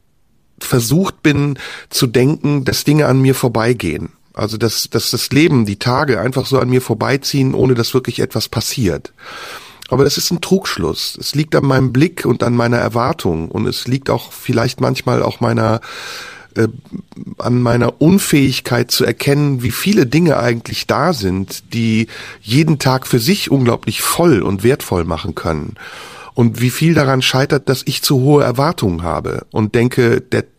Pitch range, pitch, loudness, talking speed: 115-145 Hz, 130 Hz, -15 LUFS, 165 wpm